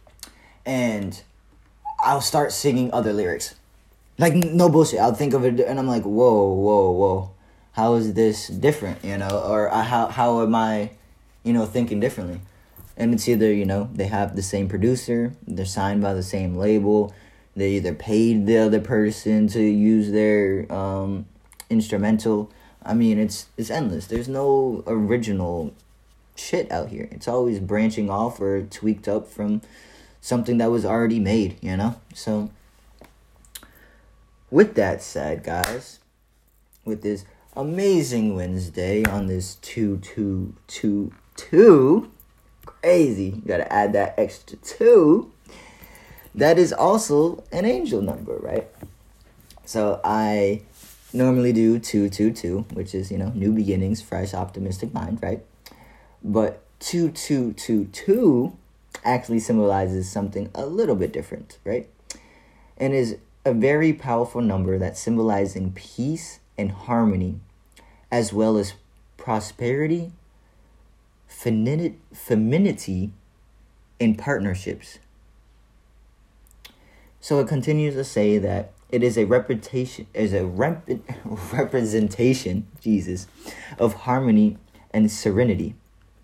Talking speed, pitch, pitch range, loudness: 130 wpm, 105 Hz, 100-120 Hz, -22 LUFS